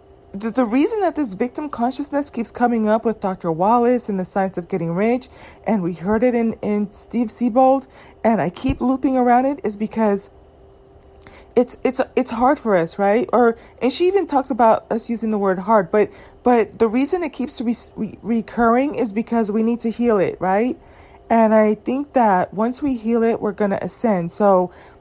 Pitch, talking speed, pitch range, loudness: 230 Hz, 195 wpm, 210-250 Hz, -19 LUFS